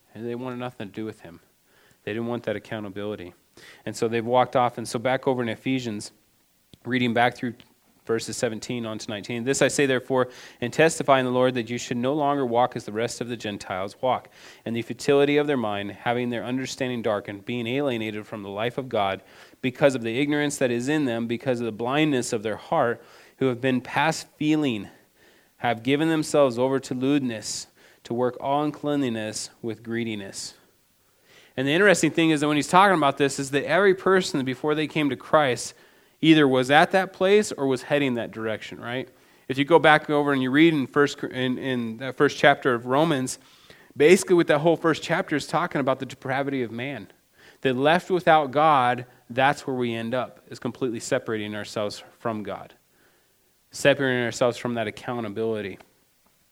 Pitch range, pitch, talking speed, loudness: 115-145 Hz, 130 Hz, 195 wpm, -24 LUFS